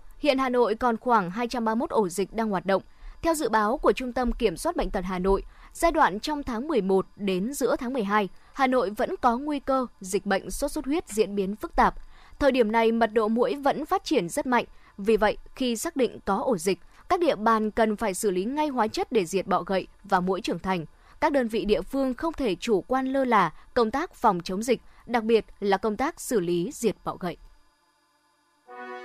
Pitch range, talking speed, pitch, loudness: 195-265 Hz, 225 wpm, 225 Hz, -26 LUFS